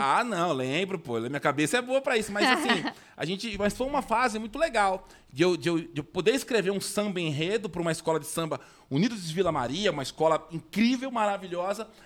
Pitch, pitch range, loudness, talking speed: 190 Hz, 160-220 Hz, -28 LUFS, 220 wpm